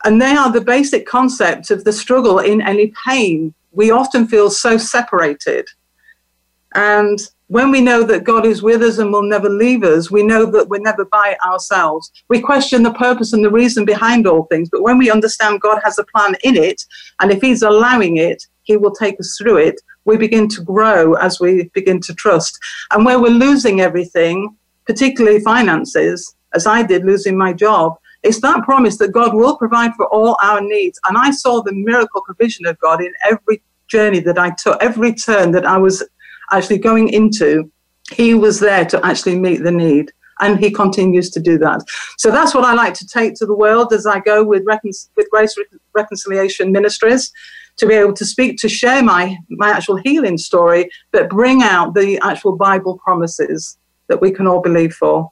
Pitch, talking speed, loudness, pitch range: 210 Hz, 200 wpm, -13 LUFS, 190-235 Hz